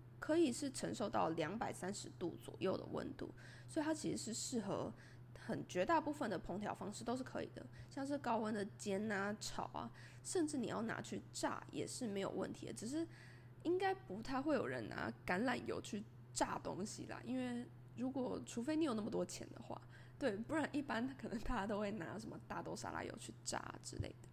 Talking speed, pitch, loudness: 290 characters per minute, 225 Hz, -43 LUFS